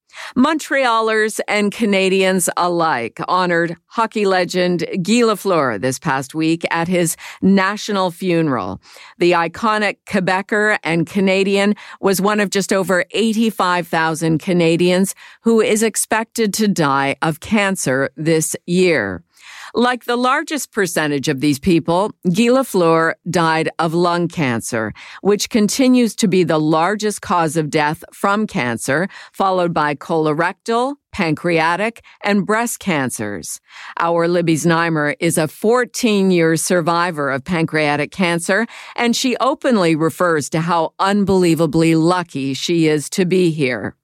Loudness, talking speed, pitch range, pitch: -17 LUFS, 125 wpm, 160-210 Hz, 180 Hz